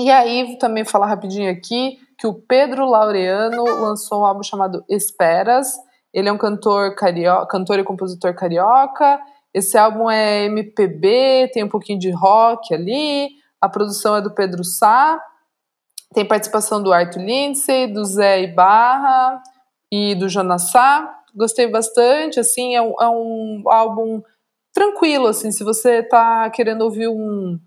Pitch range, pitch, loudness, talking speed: 200-250 Hz, 220 Hz, -16 LUFS, 145 wpm